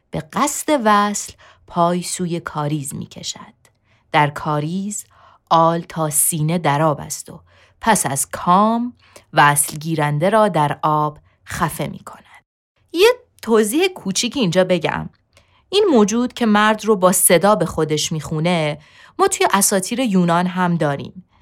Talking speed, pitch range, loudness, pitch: 135 wpm, 150-215 Hz, -17 LUFS, 175 Hz